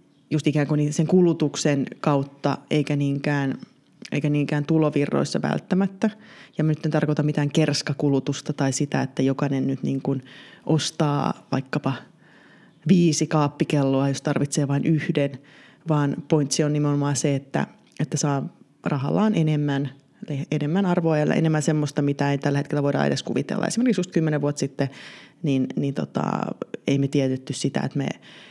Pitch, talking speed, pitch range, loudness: 150 Hz, 150 wpm, 140-160 Hz, -23 LUFS